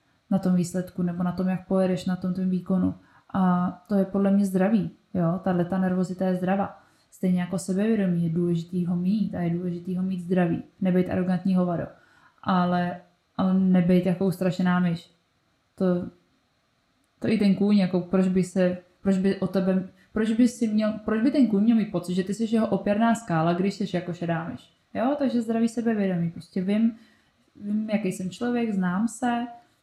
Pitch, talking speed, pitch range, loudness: 185 Hz, 185 wpm, 180-205 Hz, -25 LUFS